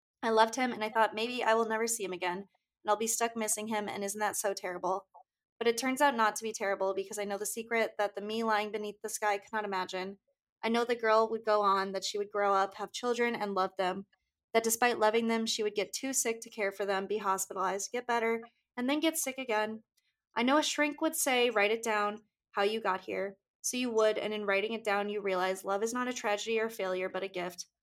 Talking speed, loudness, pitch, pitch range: 255 wpm, -32 LUFS, 215 Hz, 195-230 Hz